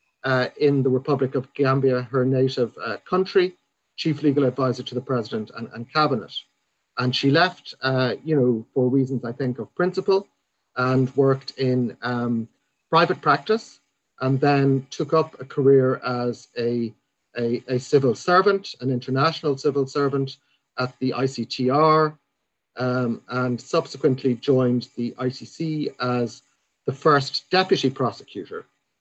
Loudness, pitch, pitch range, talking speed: -23 LUFS, 130 Hz, 125-145 Hz, 140 wpm